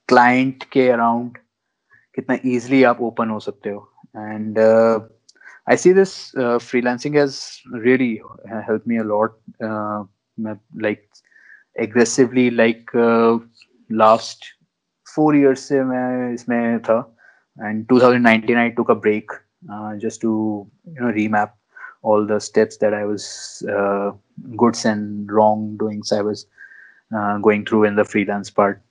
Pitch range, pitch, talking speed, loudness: 105-120 Hz, 110 Hz, 140 wpm, -18 LUFS